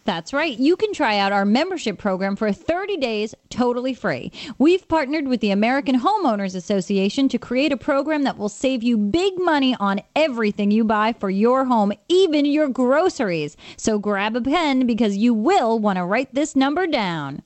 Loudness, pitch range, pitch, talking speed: -20 LUFS, 210-290 Hz, 245 Hz, 185 wpm